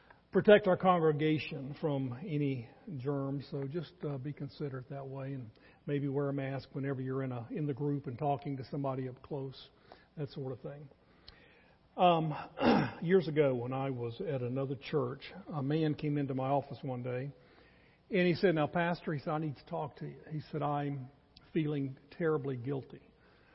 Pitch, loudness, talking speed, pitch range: 145 Hz, -34 LUFS, 180 wpm, 135-155 Hz